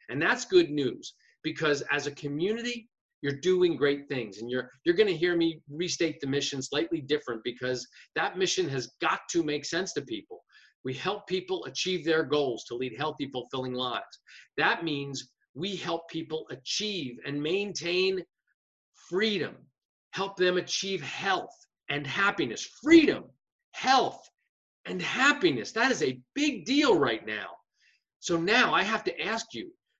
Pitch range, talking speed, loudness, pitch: 145-205 Hz, 155 wpm, -29 LUFS, 170 Hz